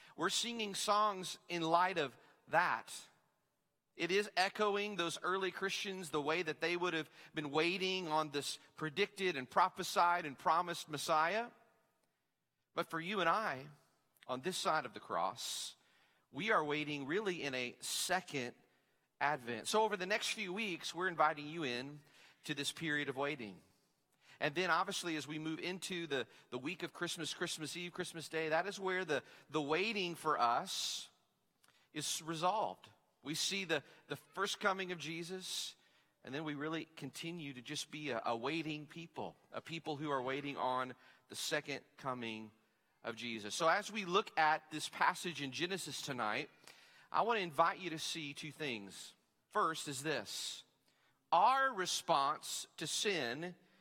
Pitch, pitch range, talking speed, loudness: 160 Hz, 145-185 Hz, 165 wpm, -38 LUFS